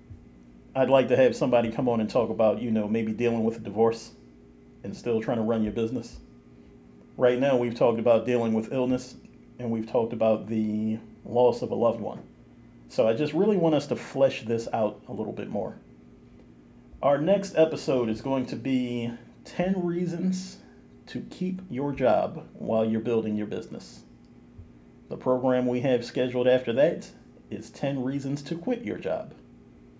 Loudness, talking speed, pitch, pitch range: -26 LUFS, 175 wpm, 115 Hz, 105-130 Hz